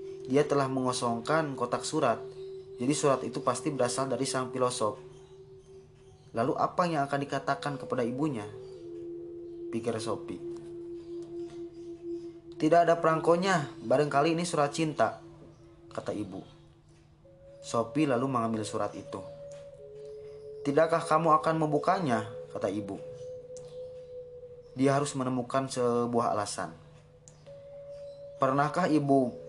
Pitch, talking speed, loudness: 155 Hz, 100 wpm, -29 LUFS